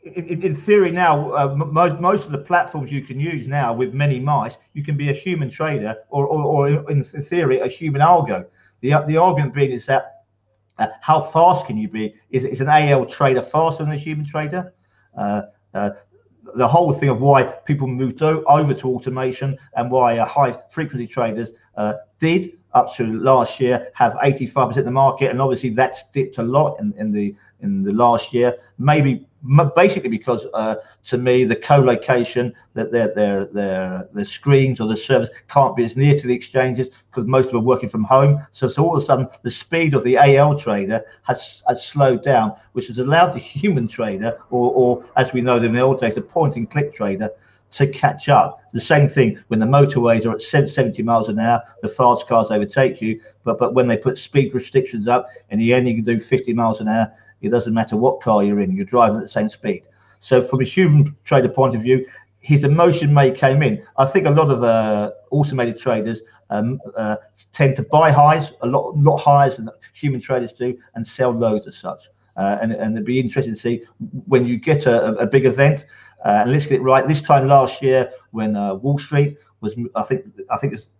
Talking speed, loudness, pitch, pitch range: 215 wpm, -18 LUFS, 130 Hz, 115-145 Hz